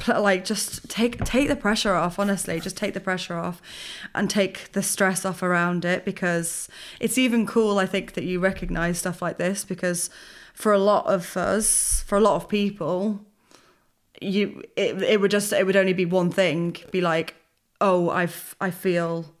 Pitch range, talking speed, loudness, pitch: 175-205 Hz, 190 wpm, -23 LUFS, 190 Hz